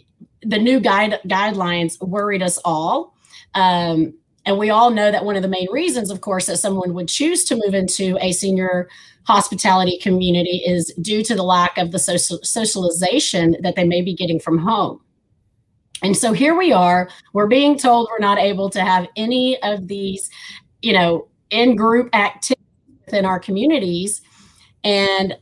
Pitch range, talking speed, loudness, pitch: 180-215 Hz, 170 wpm, -17 LUFS, 190 Hz